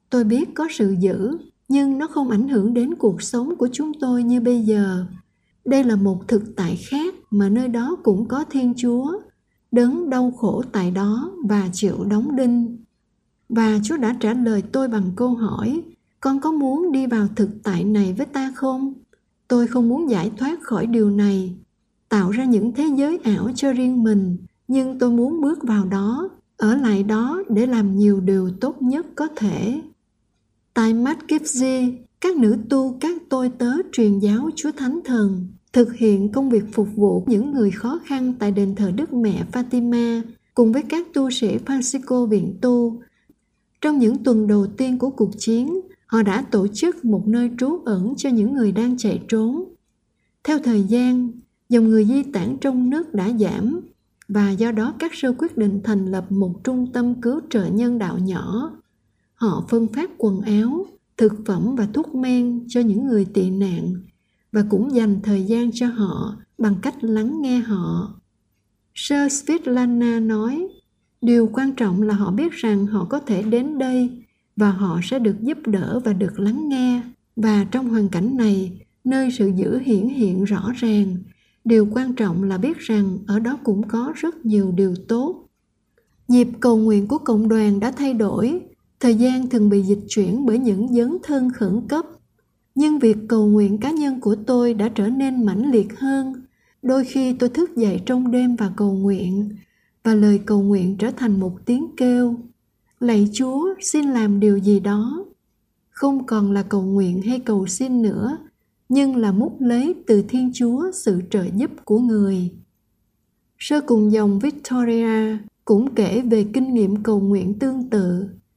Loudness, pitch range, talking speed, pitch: -20 LUFS, 205-260 Hz, 180 wpm, 235 Hz